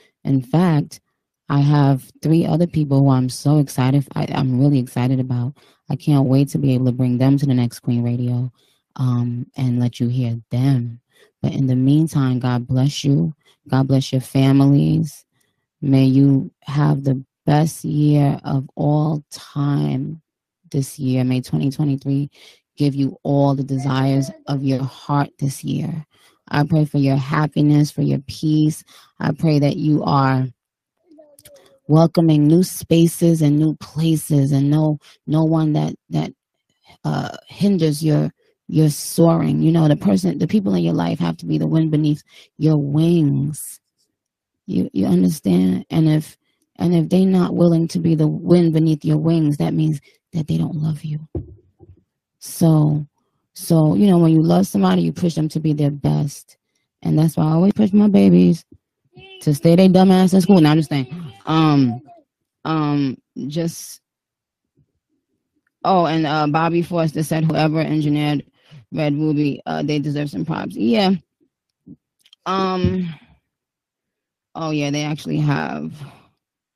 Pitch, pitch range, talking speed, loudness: 150 Hz, 135-160 Hz, 155 wpm, -18 LUFS